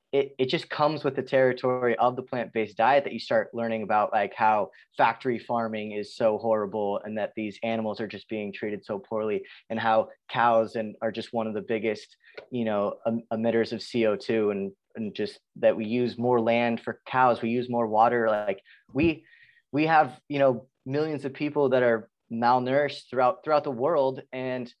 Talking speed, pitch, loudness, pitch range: 195 wpm, 120 Hz, -27 LUFS, 110-130 Hz